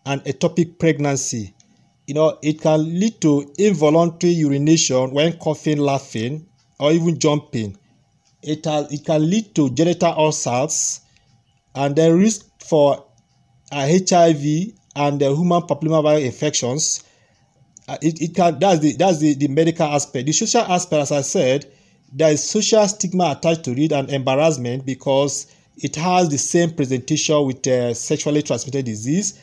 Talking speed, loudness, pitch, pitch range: 150 wpm, -18 LUFS, 150 Hz, 140-165 Hz